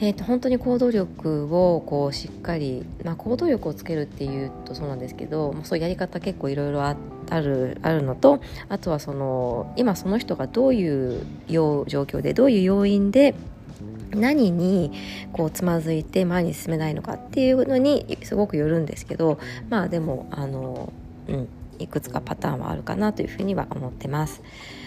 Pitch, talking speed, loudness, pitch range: 165 Hz, 355 characters per minute, -24 LUFS, 140-200 Hz